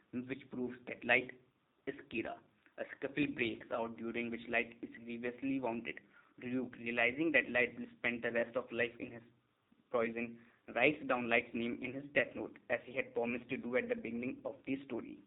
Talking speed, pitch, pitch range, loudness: 190 wpm, 120 Hz, 115-130 Hz, -38 LUFS